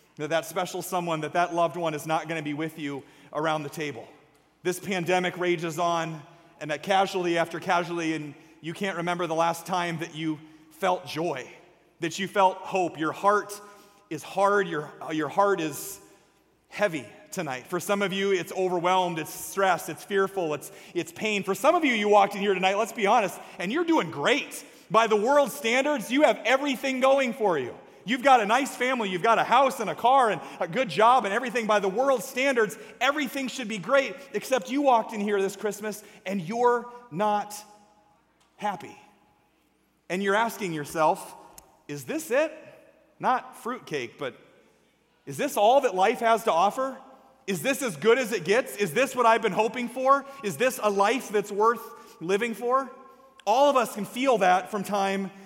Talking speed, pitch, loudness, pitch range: 190 wpm, 200 Hz, -26 LUFS, 170-240 Hz